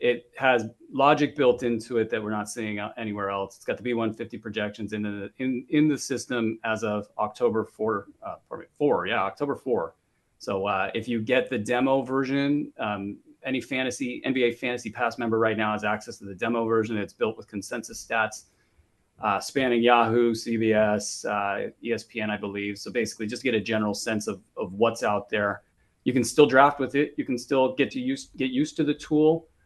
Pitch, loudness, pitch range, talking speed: 115 Hz, -26 LUFS, 105-130 Hz, 200 wpm